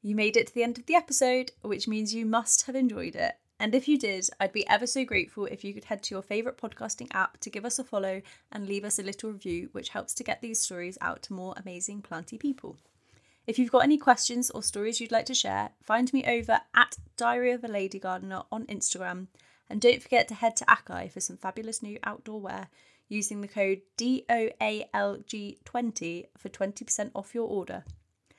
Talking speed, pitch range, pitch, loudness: 215 wpm, 195-240 Hz, 215 Hz, -29 LUFS